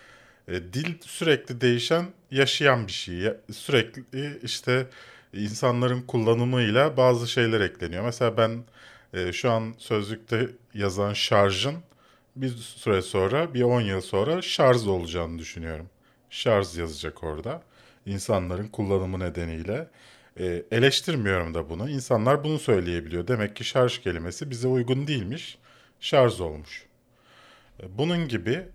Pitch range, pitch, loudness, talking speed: 95-130 Hz, 115 Hz, -26 LUFS, 110 wpm